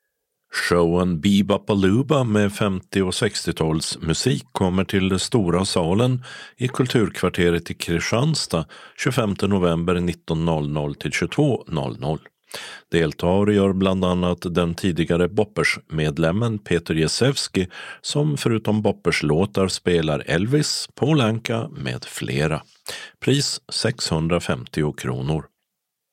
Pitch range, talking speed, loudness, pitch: 85-105 Hz, 95 wpm, -21 LUFS, 90 Hz